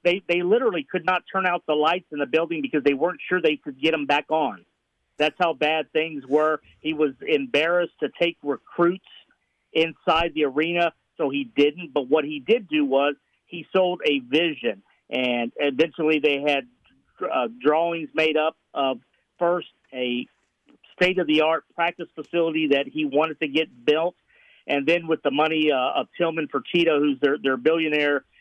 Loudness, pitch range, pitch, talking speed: -23 LUFS, 145-170 Hz, 155 Hz, 175 wpm